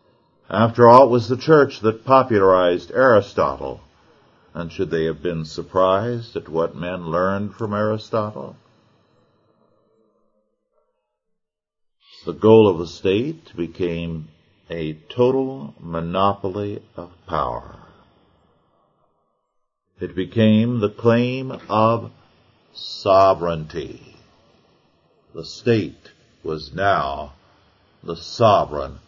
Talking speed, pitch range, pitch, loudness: 90 wpm, 85-115 Hz, 100 Hz, -19 LUFS